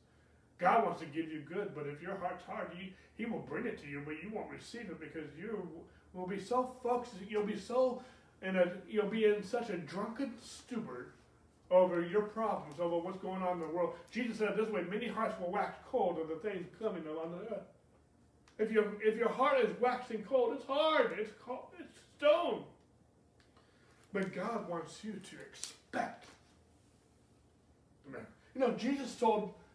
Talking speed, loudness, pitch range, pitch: 185 wpm, -36 LUFS, 180-230 Hz, 210 Hz